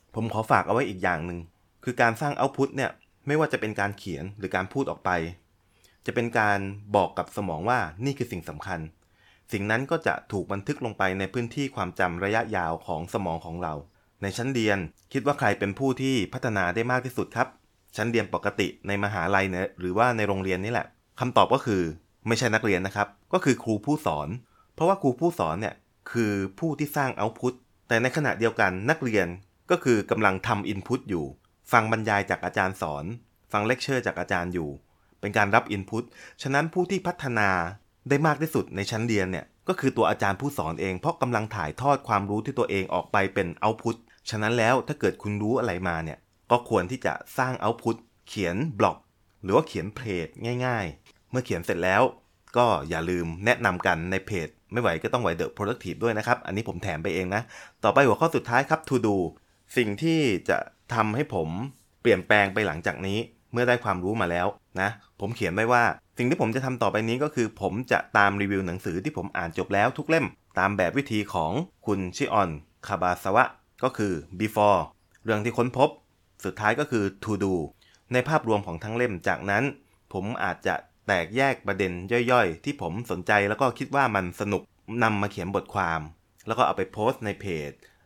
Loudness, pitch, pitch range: -26 LUFS, 105 Hz, 95-125 Hz